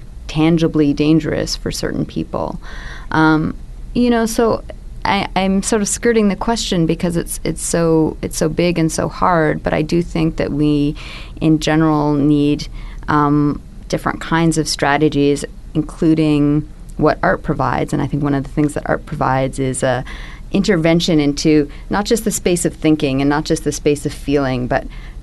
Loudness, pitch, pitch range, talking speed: -17 LUFS, 155 Hz, 145-165 Hz, 175 wpm